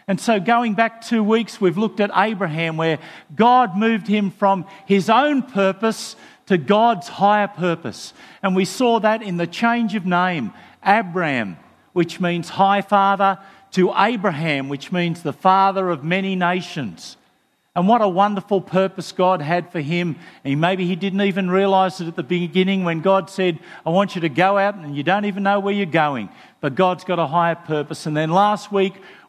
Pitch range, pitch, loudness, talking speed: 175-205 Hz, 190 Hz, -19 LUFS, 185 wpm